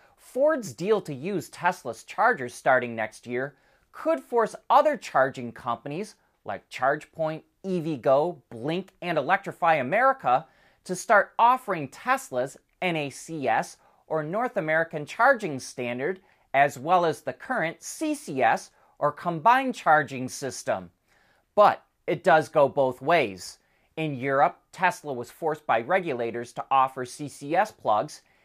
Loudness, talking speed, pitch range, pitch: -26 LUFS, 120 wpm, 130-195 Hz, 155 Hz